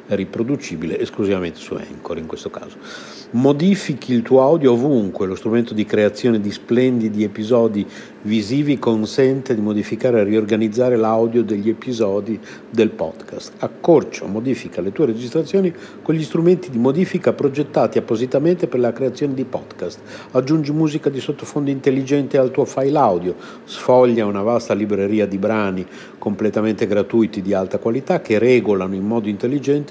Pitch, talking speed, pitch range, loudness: 120 Hz, 145 wpm, 110-140 Hz, -18 LUFS